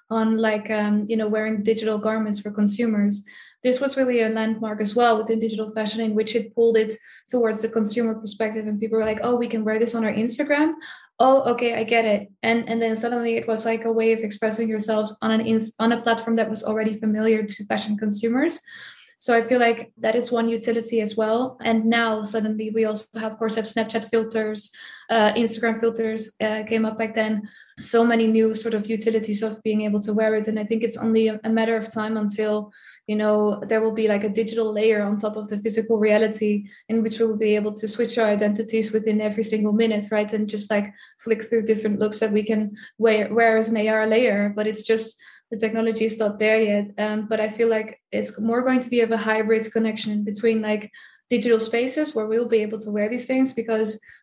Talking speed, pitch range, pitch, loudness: 225 wpm, 215-230 Hz, 220 Hz, -22 LUFS